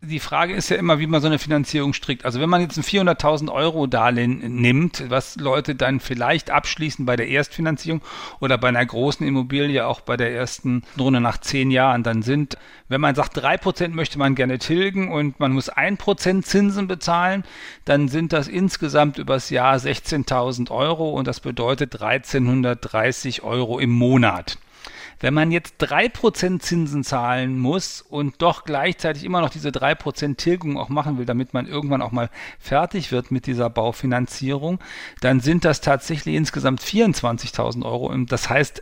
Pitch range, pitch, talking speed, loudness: 125-160 Hz, 140 Hz, 175 wpm, -21 LUFS